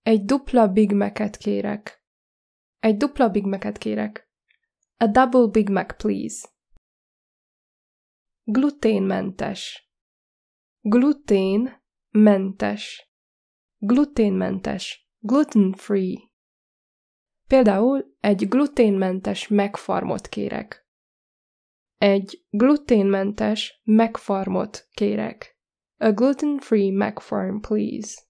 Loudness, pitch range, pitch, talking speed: -21 LUFS, 195-250 Hz, 215 Hz, 70 wpm